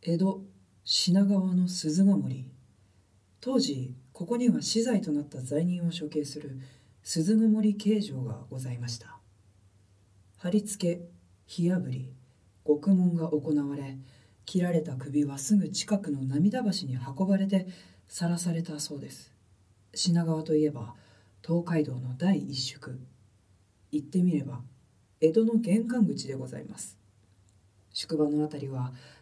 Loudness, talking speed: -29 LUFS, 240 characters per minute